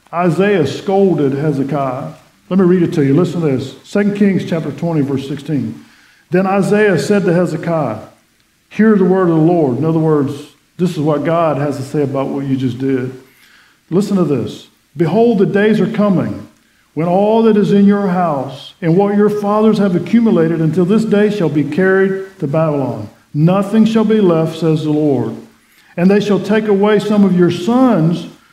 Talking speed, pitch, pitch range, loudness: 185 wpm, 170 Hz, 145-200 Hz, -14 LUFS